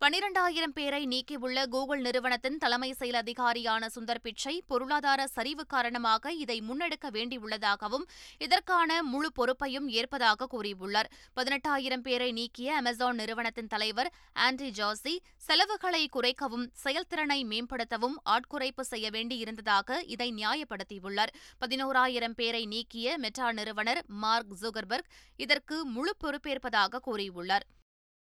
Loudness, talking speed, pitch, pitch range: -31 LUFS, 105 wpm, 250 Hz, 230-285 Hz